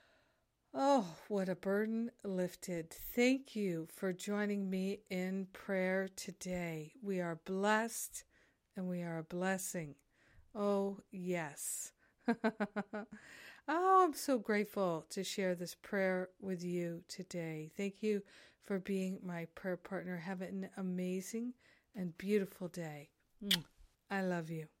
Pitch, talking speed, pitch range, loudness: 190 Hz, 120 wpm, 180-205 Hz, -39 LUFS